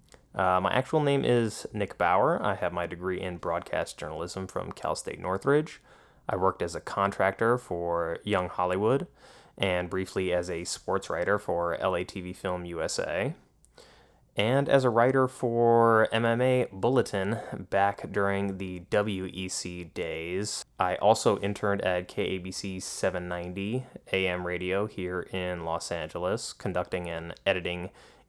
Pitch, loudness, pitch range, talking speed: 95 Hz, -29 LUFS, 90-105 Hz, 135 wpm